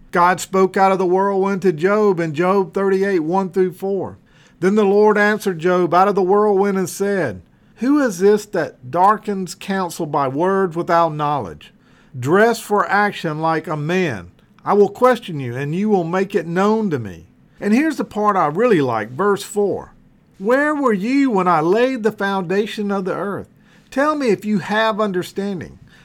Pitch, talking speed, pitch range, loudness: 195 Hz, 180 wpm, 180-210 Hz, -18 LUFS